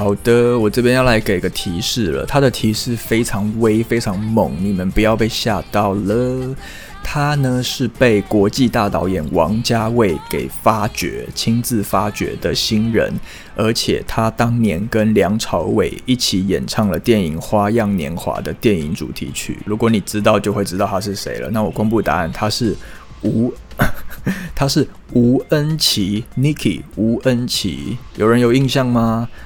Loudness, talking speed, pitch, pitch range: -17 LUFS, 240 characters per minute, 110 Hz, 105-120 Hz